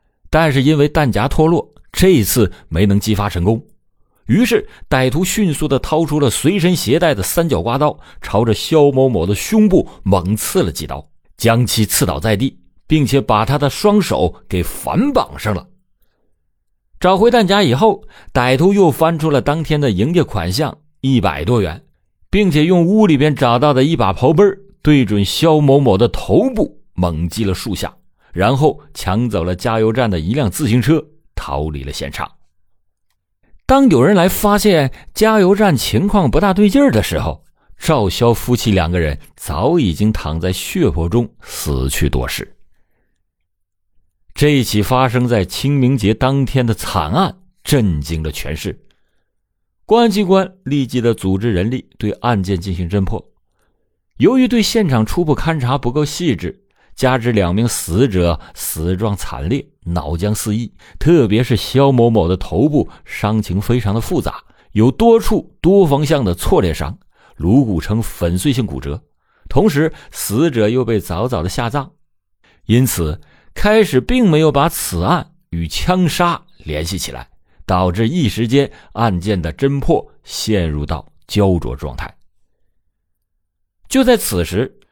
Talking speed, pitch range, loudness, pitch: 225 characters per minute, 90-150 Hz, -15 LUFS, 115 Hz